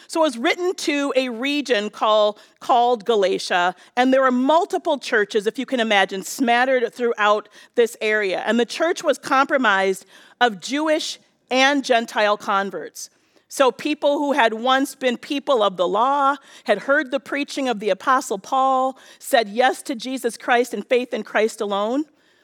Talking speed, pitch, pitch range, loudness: 165 wpm, 255 Hz, 215-280 Hz, -20 LUFS